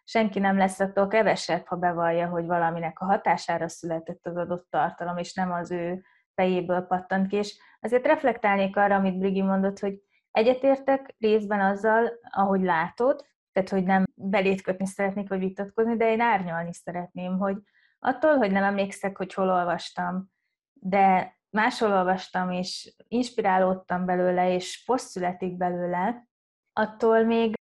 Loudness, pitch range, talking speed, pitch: -26 LUFS, 180-215 Hz, 145 wpm, 195 Hz